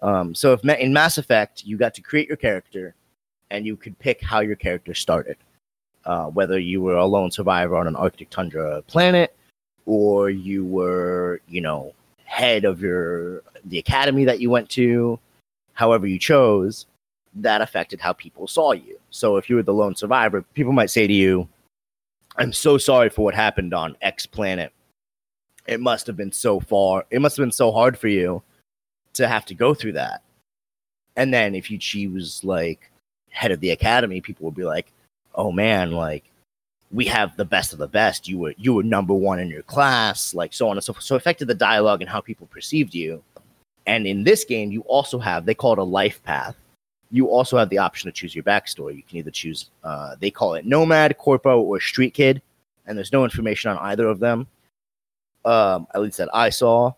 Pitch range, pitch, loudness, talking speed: 90-130 Hz, 105 Hz, -20 LUFS, 205 wpm